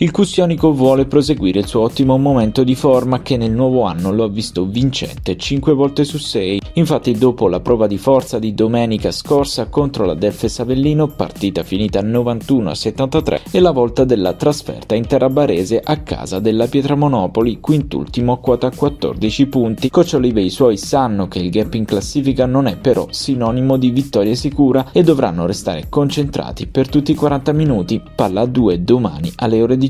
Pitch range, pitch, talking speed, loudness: 110-145 Hz, 130 Hz, 175 wpm, -15 LUFS